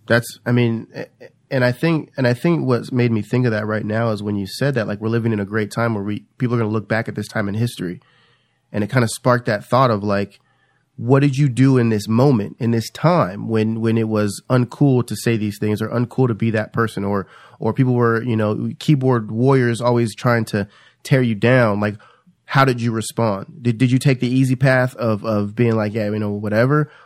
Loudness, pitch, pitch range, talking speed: -19 LUFS, 115 Hz, 110-130 Hz, 245 wpm